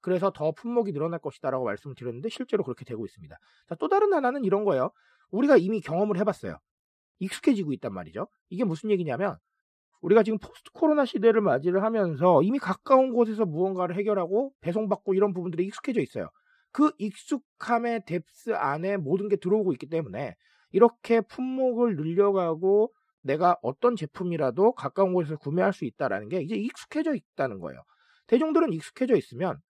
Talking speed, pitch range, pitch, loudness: 415 characters per minute, 180-240 Hz, 205 Hz, -26 LUFS